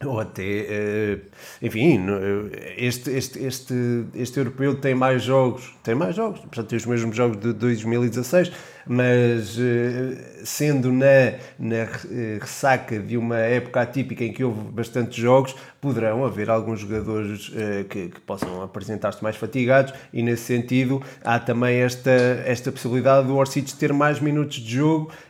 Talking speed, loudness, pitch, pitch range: 140 wpm, -23 LUFS, 125 Hz, 115-135 Hz